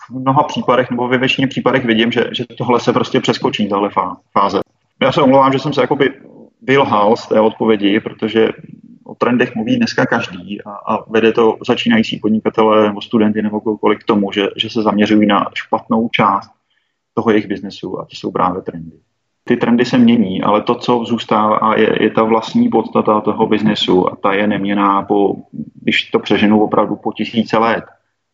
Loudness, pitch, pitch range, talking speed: -14 LUFS, 110 Hz, 105-125 Hz, 185 wpm